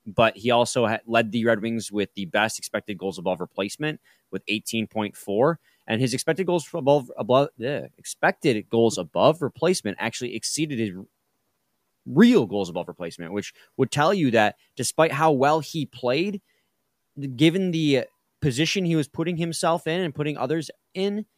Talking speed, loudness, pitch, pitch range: 160 wpm, -24 LUFS, 130 Hz, 110-160 Hz